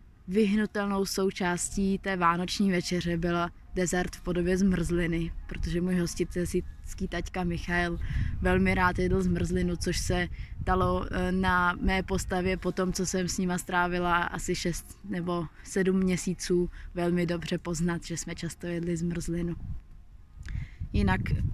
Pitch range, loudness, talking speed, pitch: 170-185 Hz, -29 LUFS, 130 wpm, 175 Hz